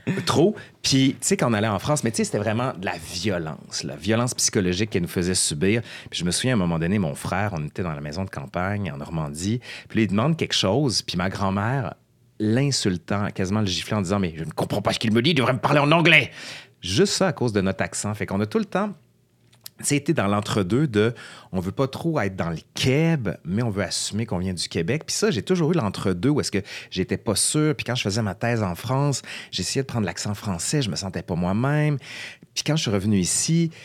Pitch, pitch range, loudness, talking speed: 110 Hz, 95-135 Hz, -23 LUFS, 250 wpm